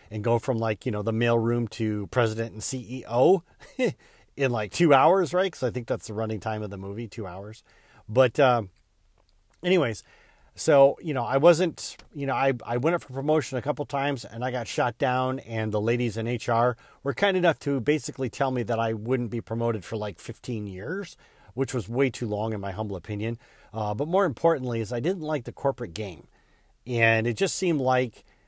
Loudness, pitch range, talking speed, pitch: -26 LUFS, 110-140 Hz, 210 wpm, 120 Hz